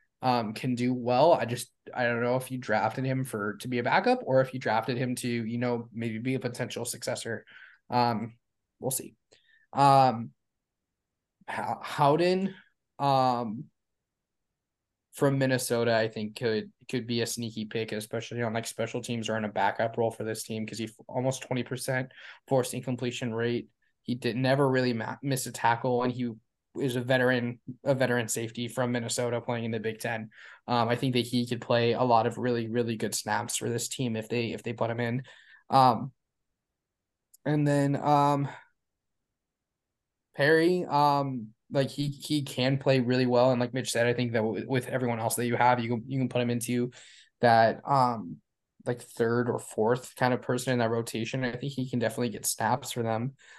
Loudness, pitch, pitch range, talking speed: -28 LUFS, 120 Hz, 115-130 Hz, 190 wpm